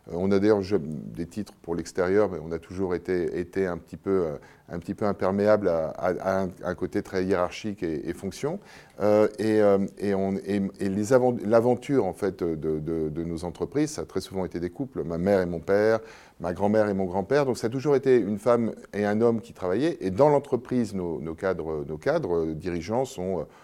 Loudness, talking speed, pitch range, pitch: -26 LUFS, 220 wpm, 90-110 Hz, 95 Hz